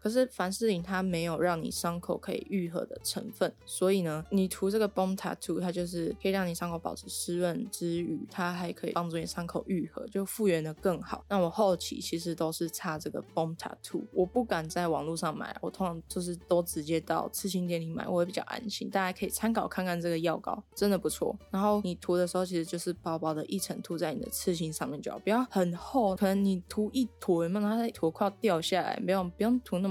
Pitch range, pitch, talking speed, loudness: 170-200 Hz, 180 Hz, 375 characters per minute, -32 LUFS